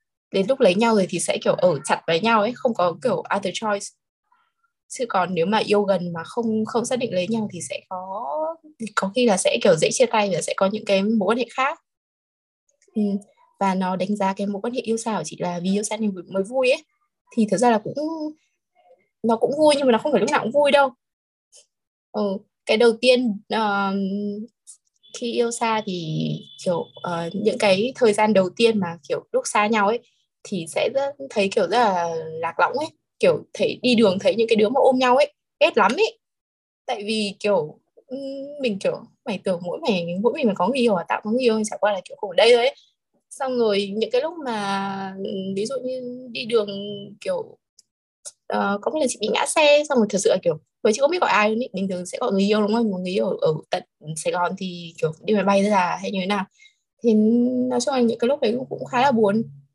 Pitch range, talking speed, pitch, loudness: 195-260 Hz, 235 wpm, 220 Hz, -22 LUFS